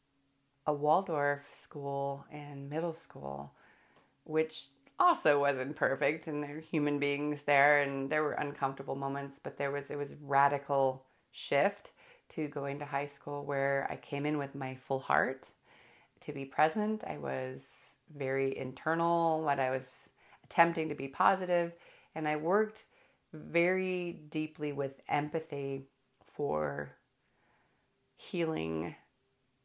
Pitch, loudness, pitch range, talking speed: 145 Hz, -33 LUFS, 135-155 Hz, 130 wpm